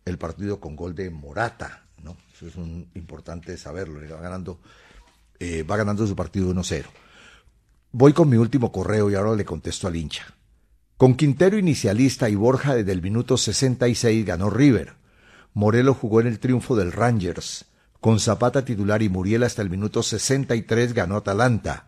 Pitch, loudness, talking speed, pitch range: 105 Hz, -21 LUFS, 165 wpm, 90-120 Hz